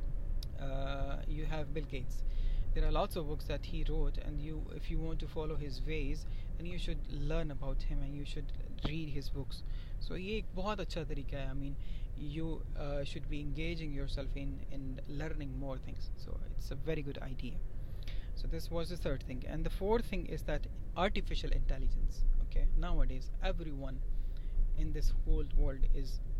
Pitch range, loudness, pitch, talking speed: 120-155 Hz, -41 LUFS, 140 Hz, 175 wpm